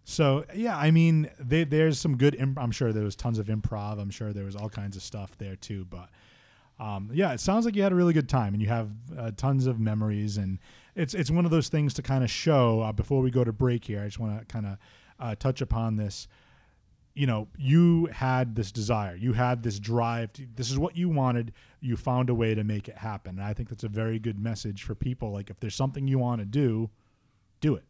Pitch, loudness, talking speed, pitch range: 115 Hz, -28 LUFS, 250 wpm, 105-135 Hz